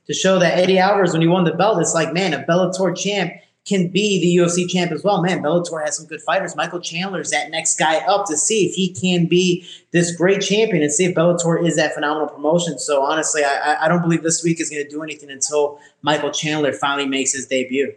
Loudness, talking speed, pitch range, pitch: -18 LUFS, 245 wpm, 150-180 Hz, 165 Hz